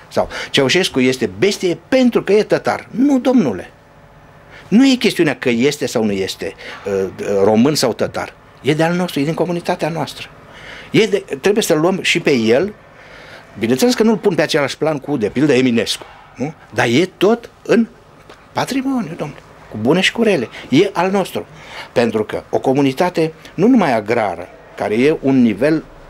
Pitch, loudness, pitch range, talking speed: 165 Hz, -16 LUFS, 140-205 Hz, 170 wpm